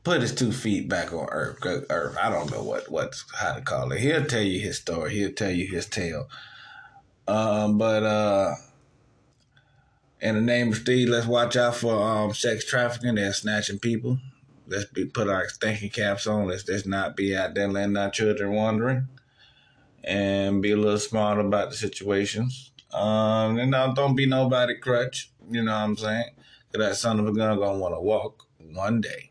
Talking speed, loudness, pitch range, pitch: 190 wpm, -25 LUFS, 105-125 Hz, 110 Hz